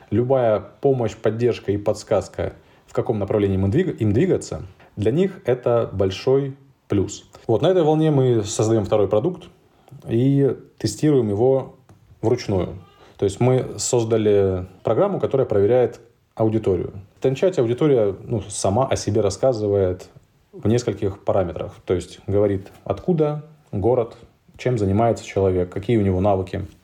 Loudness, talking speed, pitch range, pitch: -21 LUFS, 130 wpm, 100-130 Hz, 110 Hz